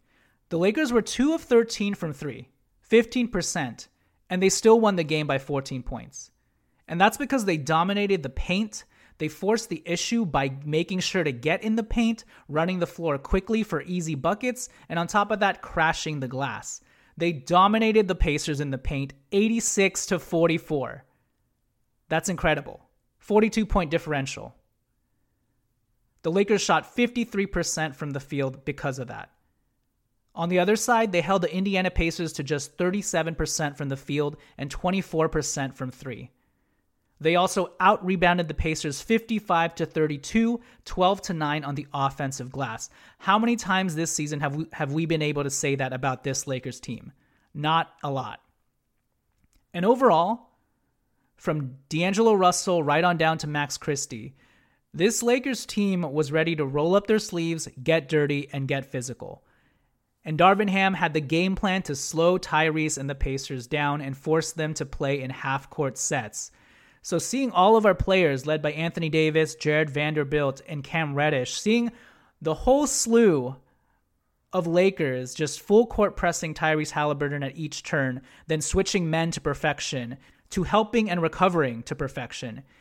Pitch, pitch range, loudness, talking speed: 160 Hz, 145-190 Hz, -25 LUFS, 160 wpm